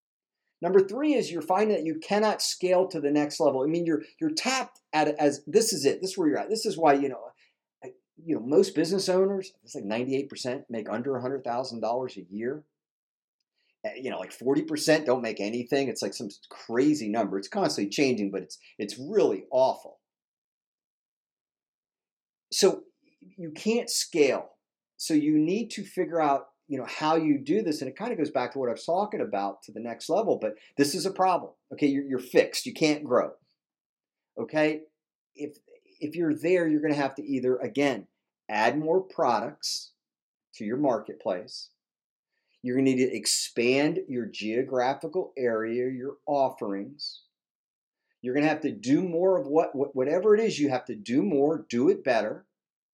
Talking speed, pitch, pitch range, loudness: 185 wpm, 155 Hz, 135-195 Hz, -27 LUFS